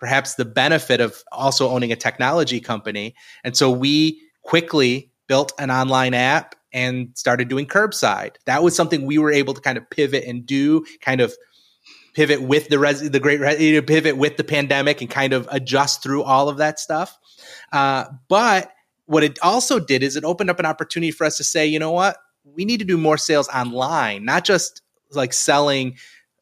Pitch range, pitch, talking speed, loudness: 130-155 Hz, 145 Hz, 195 wpm, -19 LUFS